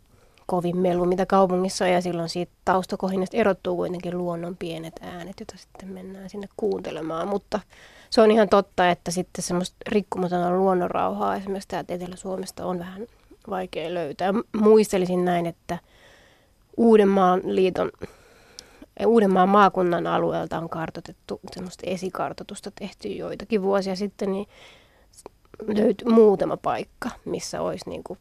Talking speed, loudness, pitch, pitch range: 130 wpm, -23 LUFS, 190 Hz, 180-205 Hz